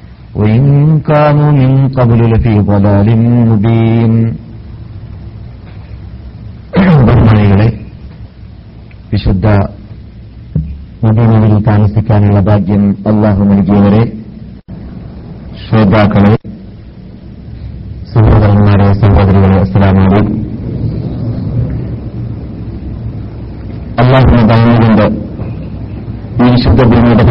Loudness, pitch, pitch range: -9 LUFS, 110 Hz, 100-115 Hz